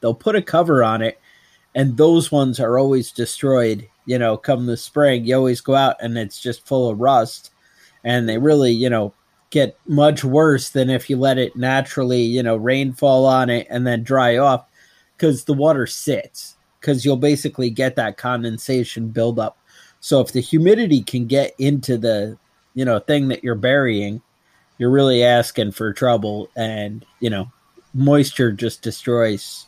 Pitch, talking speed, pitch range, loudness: 125 Hz, 175 wpm, 115-140 Hz, -18 LUFS